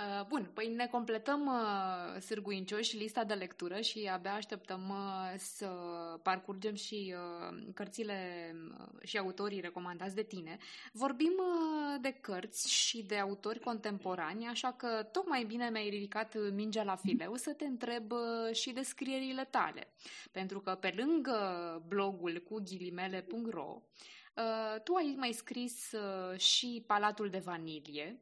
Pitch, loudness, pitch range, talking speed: 215 Hz, -38 LUFS, 190-240 Hz, 125 wpm